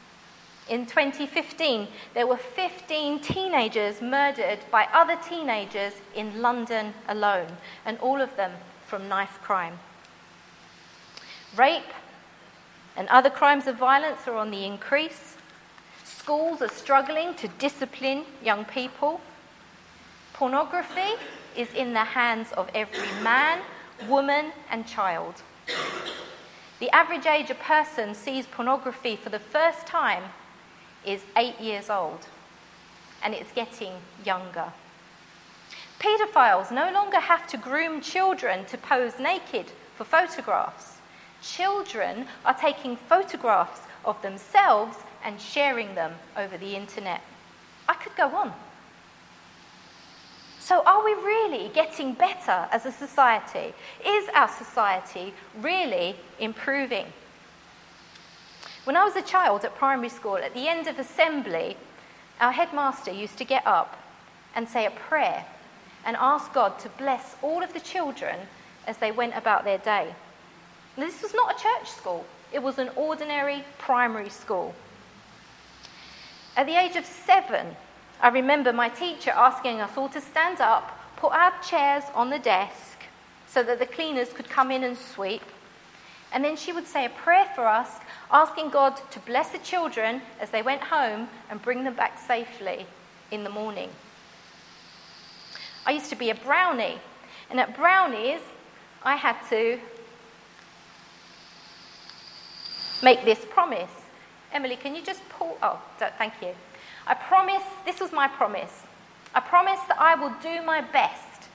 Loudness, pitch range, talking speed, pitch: -25 LUFS, 225-320 Hz, 135 wpm, 270 Hz